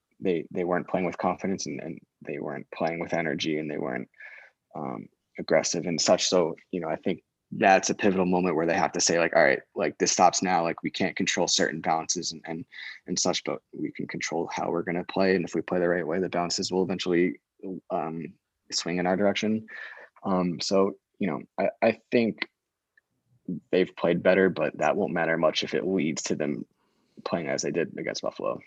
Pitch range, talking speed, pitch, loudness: 85-95 Hz, 215 wpm, 90 Hz, -27 LUFS